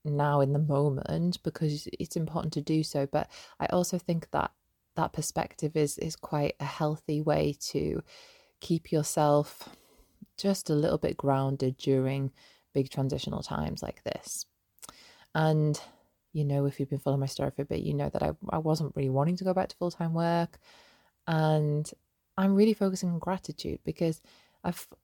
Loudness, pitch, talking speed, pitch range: -30 LUFS, 155 Hz, 175 wpm, 140-170 Hz